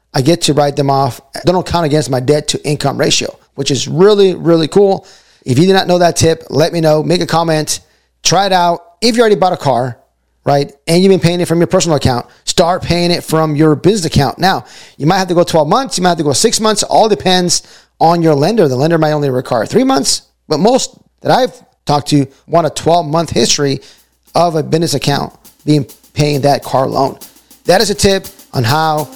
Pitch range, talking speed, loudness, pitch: 145-180 Hz, 230 wpm, -12 LUFS, 160 Hz